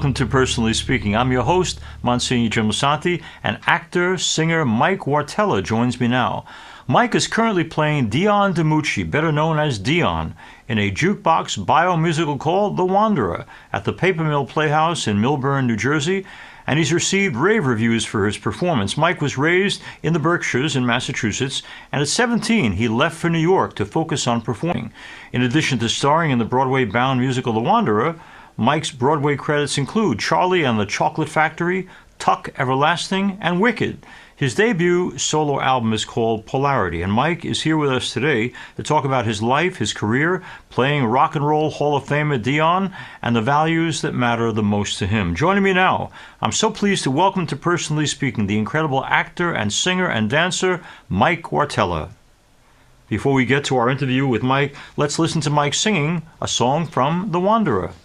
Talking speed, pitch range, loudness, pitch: 180 wpm, 125-170 Hz, -19 LUFS, 145 Hz